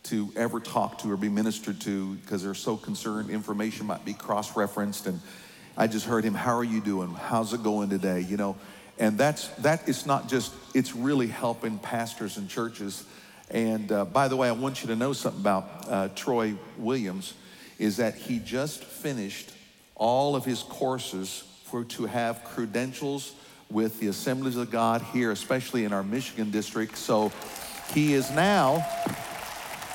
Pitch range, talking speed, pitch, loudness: 105-130 Hz, 175 wpm, 115 Hz, -29 LUFS